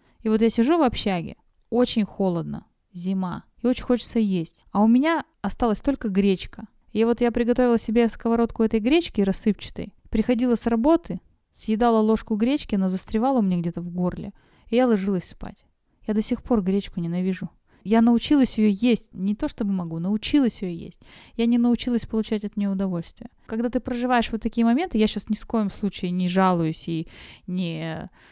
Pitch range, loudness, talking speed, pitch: 190-240 Hz, -23 LUFS, 180 wpm, 220 Hz